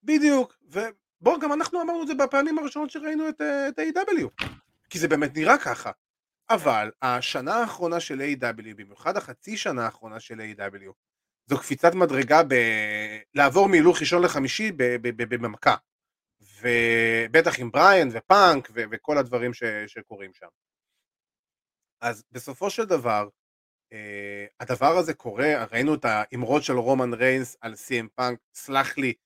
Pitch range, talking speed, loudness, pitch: 115-180 Hz, 140 wpm, -23 LUFS, 130 Hz